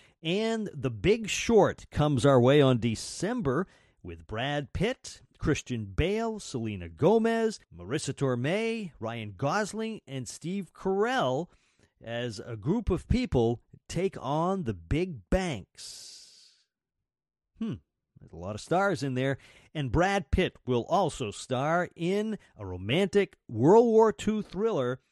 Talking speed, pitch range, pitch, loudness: 130 wpm, 120-195 Hz, 145 Hz, -29 LUFS